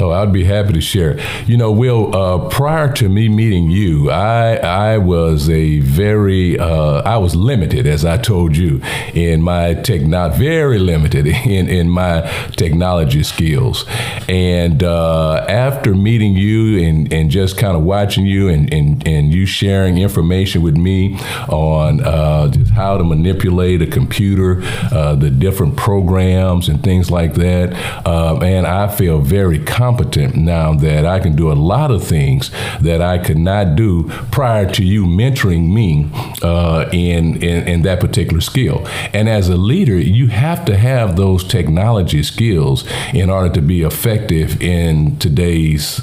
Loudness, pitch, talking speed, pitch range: -13 LUFS, 95 Hz, 165 wpm, 85-110 Hz